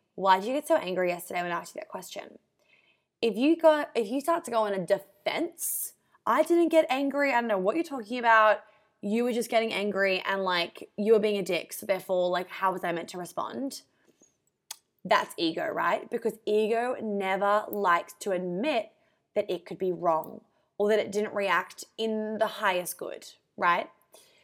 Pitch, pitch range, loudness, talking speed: 215 Hz, 190-260 Hz, -28 LUFS, 195 wpm